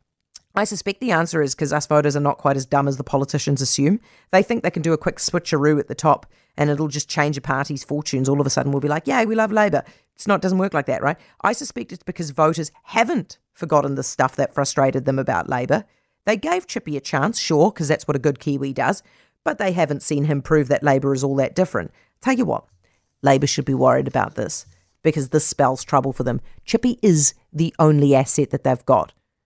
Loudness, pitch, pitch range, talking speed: -20 LUFS, 150 Hz, 140-180 Hz, 235 wpm